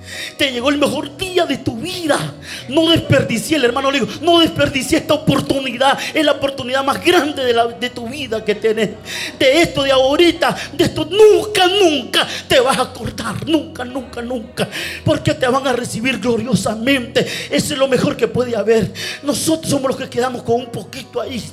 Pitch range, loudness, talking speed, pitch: 245-310 Hz, -16 LUFS, 185 wpm, 270 Hz